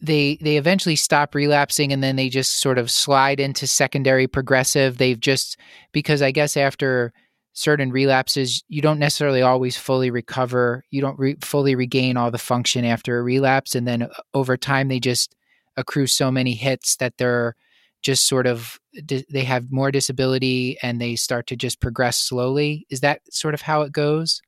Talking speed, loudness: 180 wpm, -20 LUFS